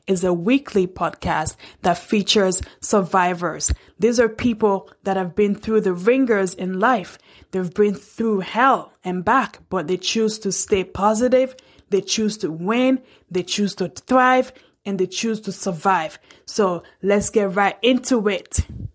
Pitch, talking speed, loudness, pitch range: 200 Hz, 155 wpm, -20 LUFS, 185-225 Hz